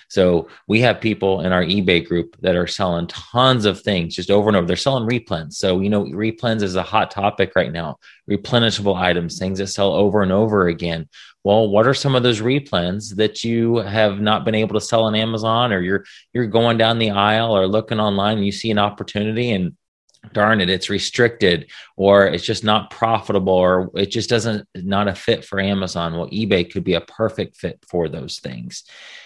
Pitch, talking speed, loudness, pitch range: 100 Hz, 205 wpm, -18 LUFS, 95-110 Hz